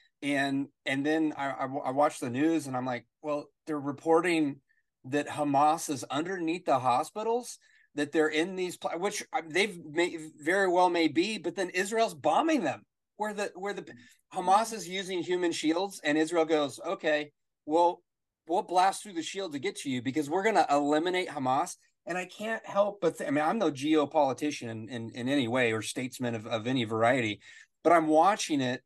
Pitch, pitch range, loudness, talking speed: 155 Hz, 145-185 Hz, -29 LUFS, 190 wpm